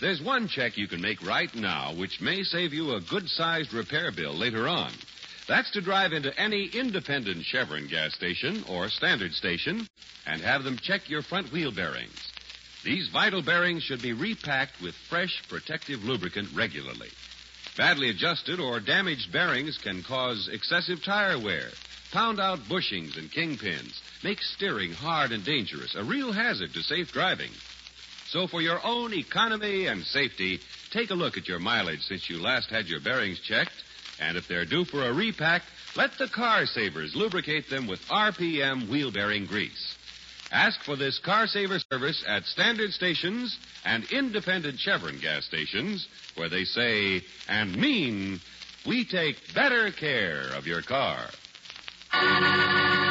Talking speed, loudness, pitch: 160 wpm, -27 LUFS, 160 Hz